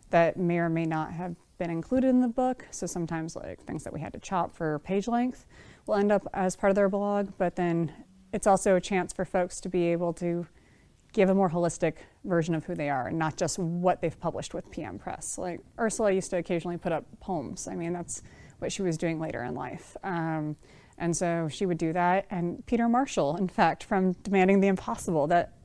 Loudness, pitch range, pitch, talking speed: -29 LUFS, 165-195 Hz, 175 Hz, 225 wpm